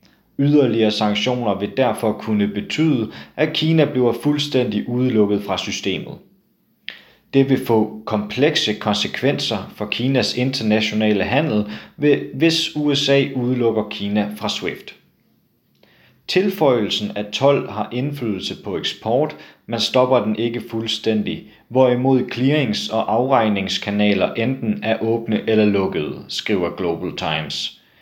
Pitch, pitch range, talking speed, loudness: 115 Hz, 105-130 Hz, 110 wpm, -19 LUFS